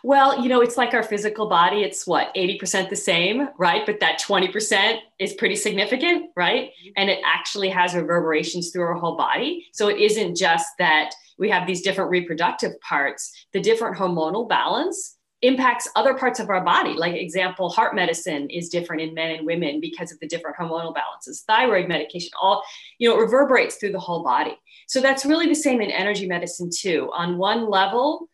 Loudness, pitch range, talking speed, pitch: -21 LUFS, 175-240 Hz, 190 wpm, 195 Hz